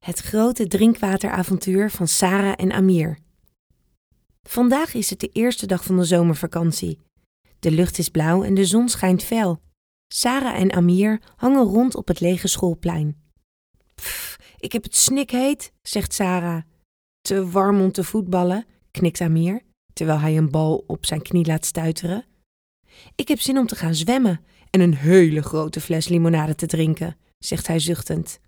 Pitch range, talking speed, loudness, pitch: 165-210 Hz, 160 wpm, -20 LUFS, 180 Hz